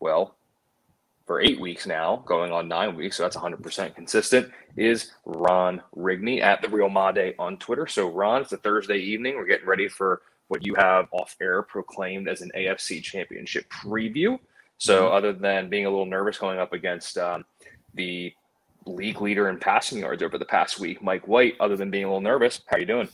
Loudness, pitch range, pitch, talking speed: -25 LUFS, 95-105 Hz, 95 Hz, 195 wpm